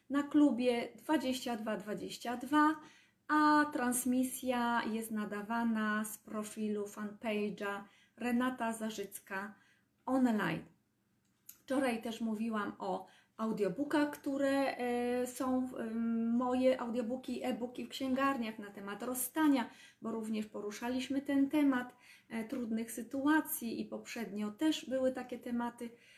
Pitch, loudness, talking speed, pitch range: 245 Hz, -36 LUFS, 95 wpm, 220-260 Hz